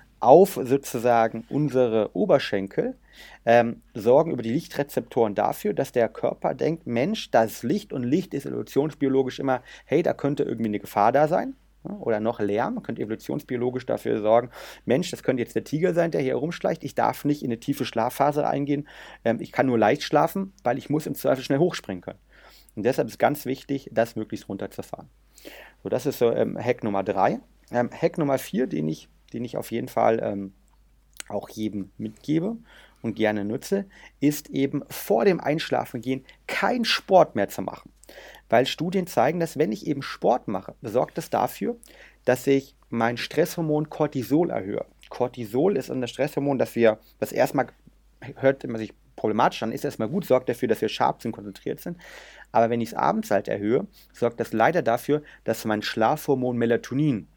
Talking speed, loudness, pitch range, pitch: 180 wpm, -25 LUFS, 110-145 Hz, 125 Hz